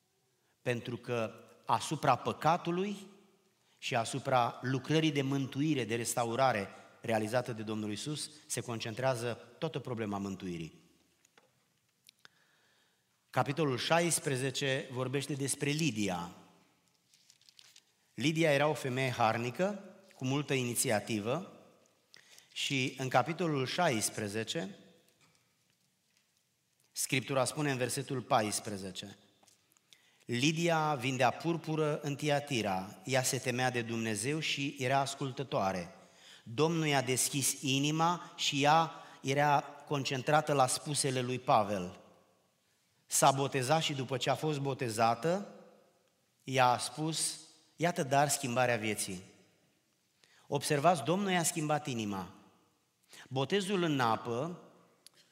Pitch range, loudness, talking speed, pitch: 120-155 Hz, -33 LUFS, 95 wpm, 135 Hz